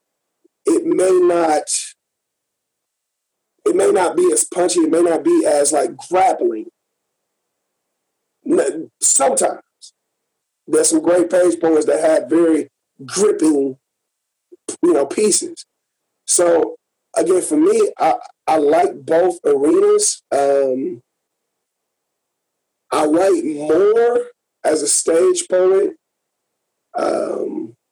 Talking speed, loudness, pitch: 100 wpm, -16 LUFS, 345 Hz